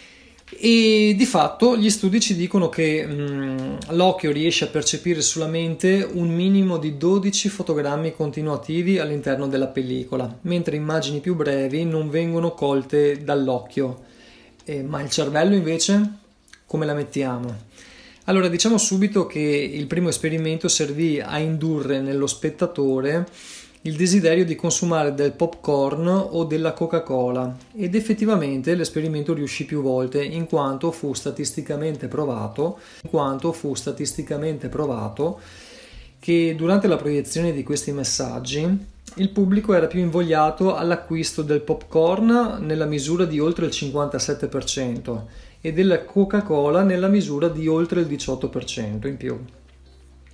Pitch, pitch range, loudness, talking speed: 155 Hz, 140-175 Hz, -22 LUFS, 130 wpm